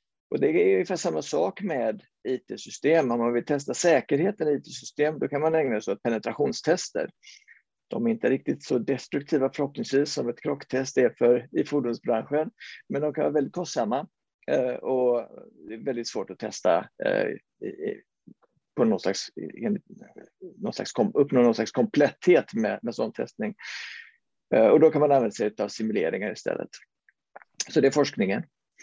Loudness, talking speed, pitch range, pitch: -26 LUFS, 155 wpm, 125-205 Hz, 145 Hz